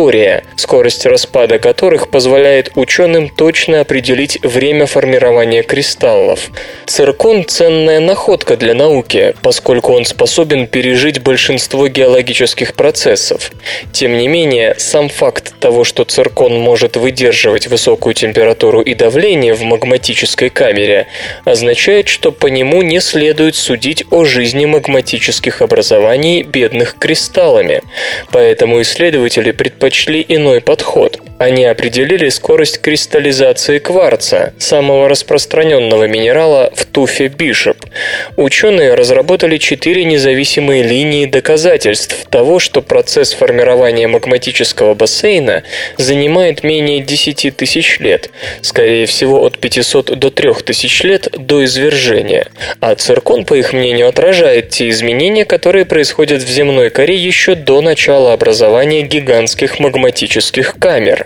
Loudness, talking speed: -9 LUFS, 115 wpm